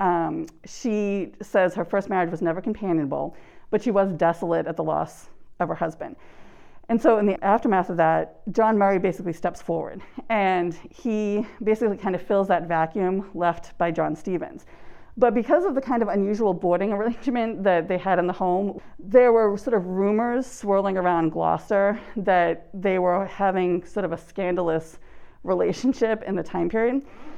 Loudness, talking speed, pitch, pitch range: -23 LUFS, 175 wpm, 195 Hz, 175-220 Hz